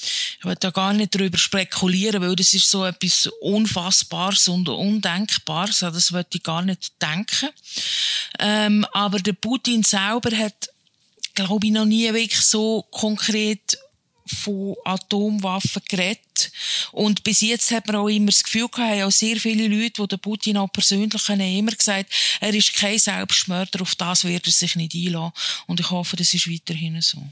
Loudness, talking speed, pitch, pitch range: -19 LUFS, 175 wpm, 200 Hz, 185-215 Hz